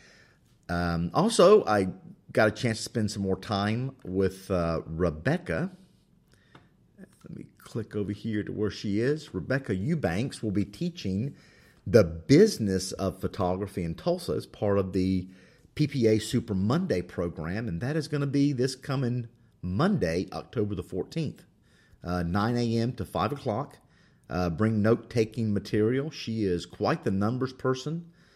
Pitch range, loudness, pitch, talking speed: 95-130 Hz, -28 LUFS, 105 Hz, 150 wpm